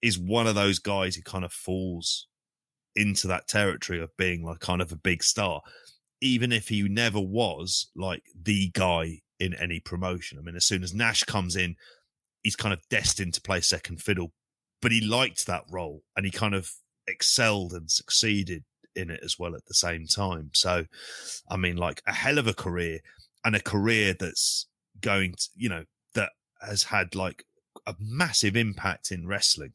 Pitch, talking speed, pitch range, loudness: 95 Hz, 190 wpm, 90-105 Hz, -27 LUFS